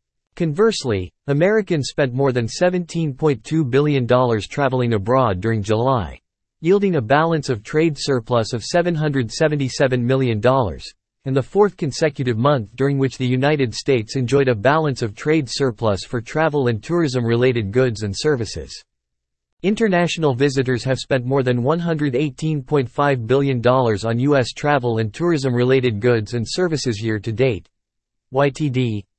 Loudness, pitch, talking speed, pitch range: -19 LUFS, 130 Hz, 135 wpm, 120-150 Hz